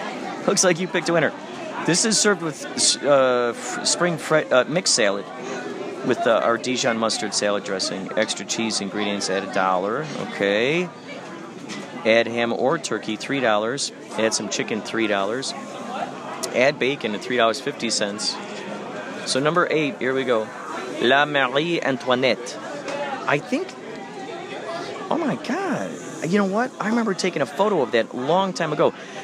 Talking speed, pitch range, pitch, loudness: 150 wpm, 115-185 Hz, 130 Hz, -22 LUFS